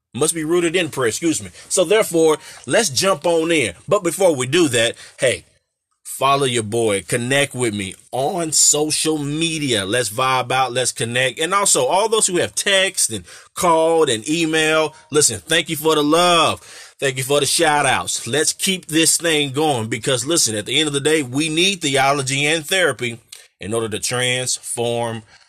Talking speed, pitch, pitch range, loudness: 185 wpm, 150 Hz, 125-165 Hz, -17 LUFS